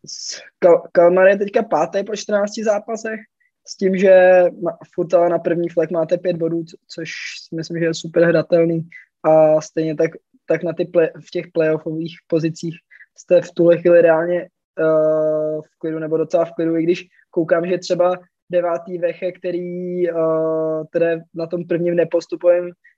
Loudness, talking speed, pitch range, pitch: -18 LUFS, 165 wpm, 165-180 Hz, 170 Hz